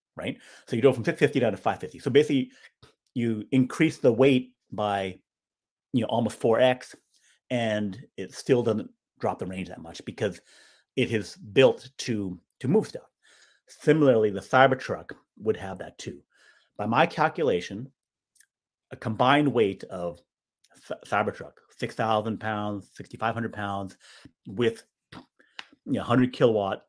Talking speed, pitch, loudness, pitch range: 155 wpm, 115 Hz, -26 LUFS, 100-125 Hz